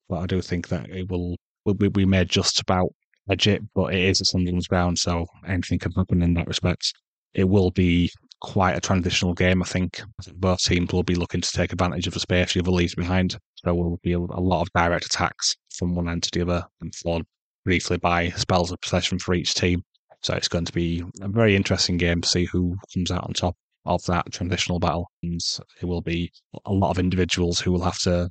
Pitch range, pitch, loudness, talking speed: 85-95 Hz, 90 Hz, -23 LUFS, 230 wpm